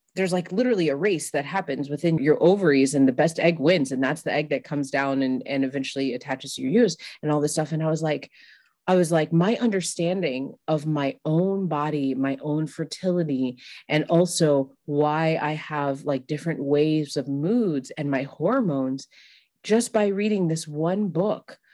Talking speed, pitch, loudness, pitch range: 190 wpm, 150 Hz, -24 LUFS, 140-175 Hz